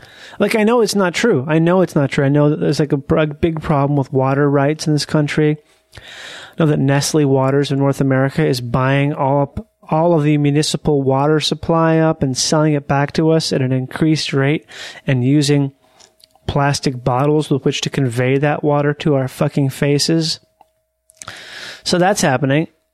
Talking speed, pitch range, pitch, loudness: 185 wpm, 140-160 Hz, 150 Hz, -16 LUFS